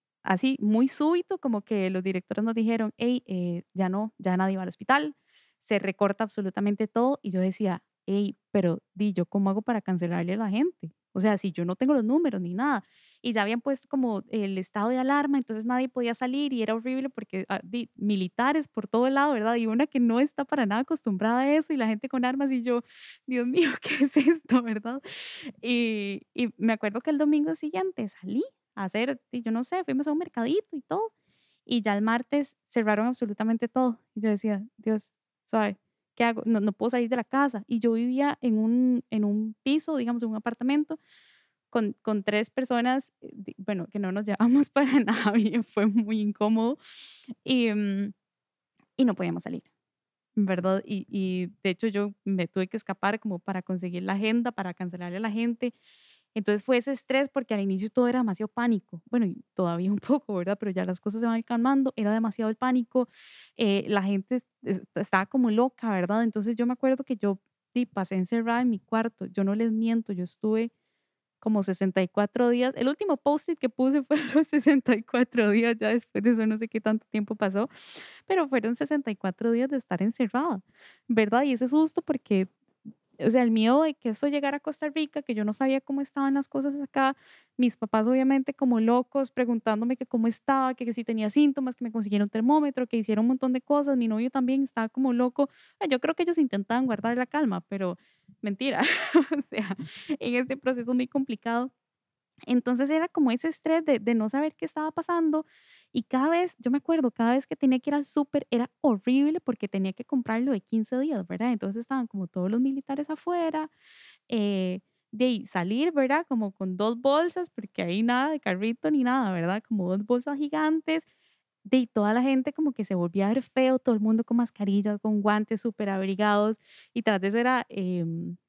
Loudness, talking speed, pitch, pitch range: -27 LUFS, 200 wpm, 235 Hz, 210-270 Hz